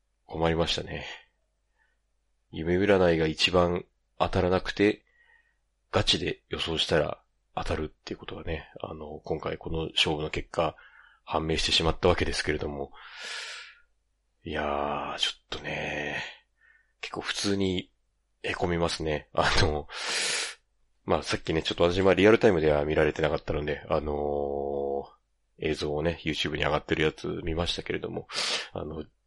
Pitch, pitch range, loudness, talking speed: 80 Hz, 75-90 Hz, -28 LUFS, 300 characters per minute